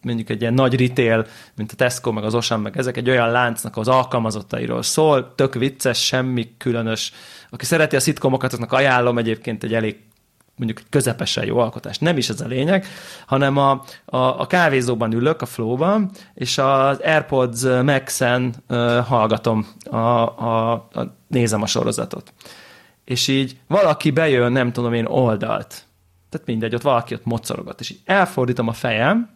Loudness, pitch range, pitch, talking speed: -19 LUFS, 115-135 Hz, 125 Hz, 160 wpm